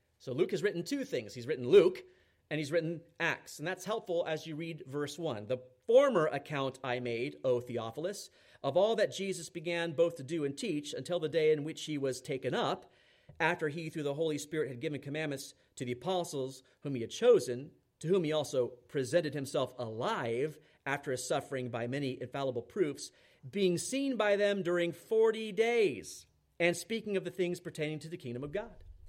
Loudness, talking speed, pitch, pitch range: -34 LUFS, 195 wpm, 155 Hz, 135-175 Hz